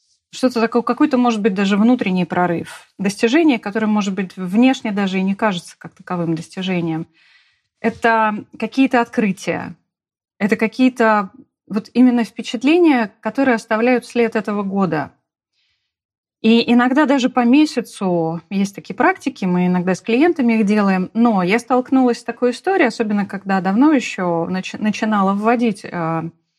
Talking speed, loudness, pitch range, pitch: 135 wpm, -17 LUFS, 190-245 Hz, 220 Hz